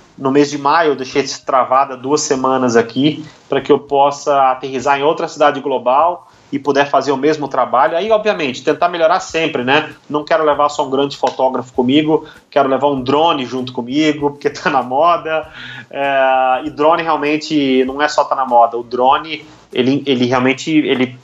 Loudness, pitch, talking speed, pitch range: -15 LUFS, 145 Hz, 185 wpm, 130-150 Hz